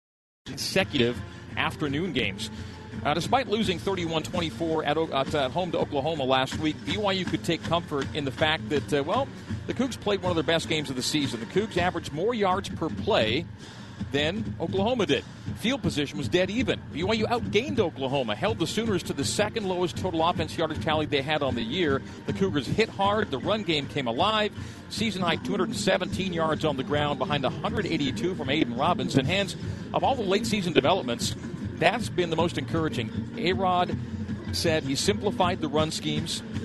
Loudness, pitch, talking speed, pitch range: -27 LUFS, 155 Hz, 185 wpm, 125-180 Hz